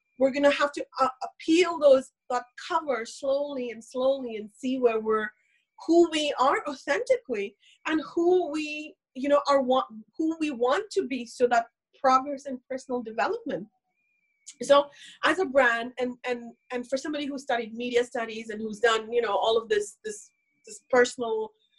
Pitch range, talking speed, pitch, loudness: 240-300 Hz, 175 wpm, 265 Hz, -27 LUFS